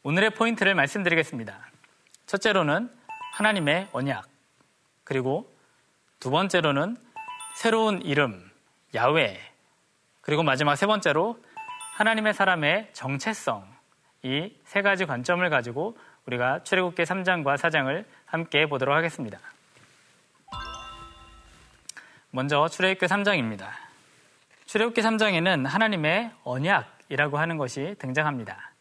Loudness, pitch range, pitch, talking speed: -25 LUFS, 140-210 Hz, 165 Hz, 260 characters per minute